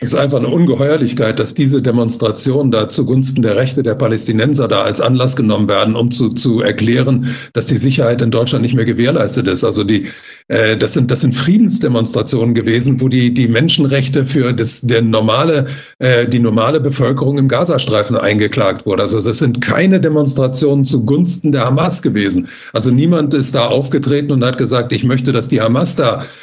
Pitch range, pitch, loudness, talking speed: 115-140 Hz, 130 Hz, -13 LUFS, 180 wpm